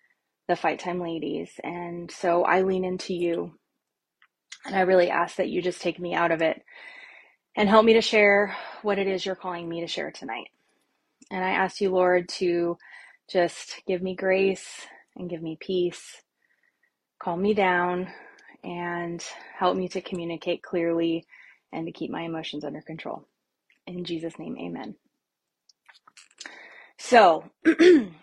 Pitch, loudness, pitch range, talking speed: 180 Hz, -25 LUFS, 170-190 Hz, 150 wpm